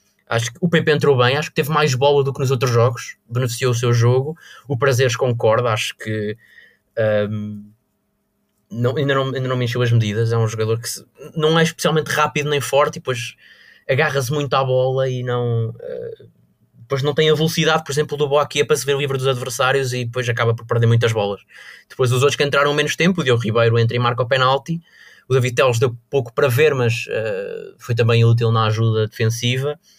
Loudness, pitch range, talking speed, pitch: -18 LUFS, 120-145 Hz, 215 wpm, 130 Hz